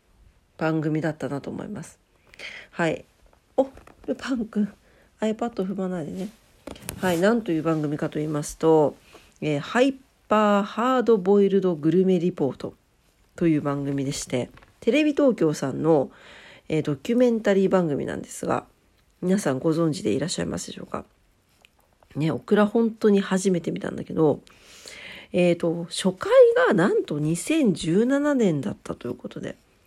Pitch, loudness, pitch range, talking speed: 185 Hz, -23 LUFS, 160-220 Hz, 270 characters per minute